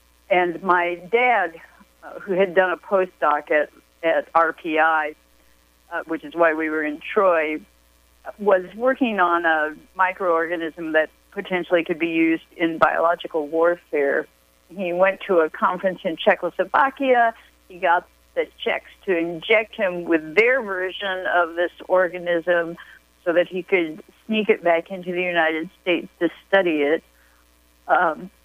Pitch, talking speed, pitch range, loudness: 175 Hz, 140 wpm, 160-185 Hz, -21 LUFS